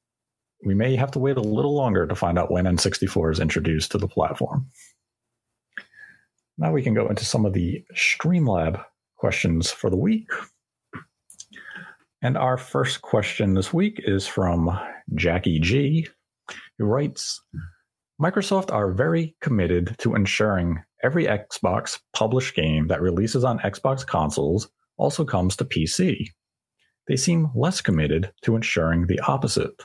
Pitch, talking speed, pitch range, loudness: 105 Hz, 140 wpm, 90-135 Hz, -23 LUFS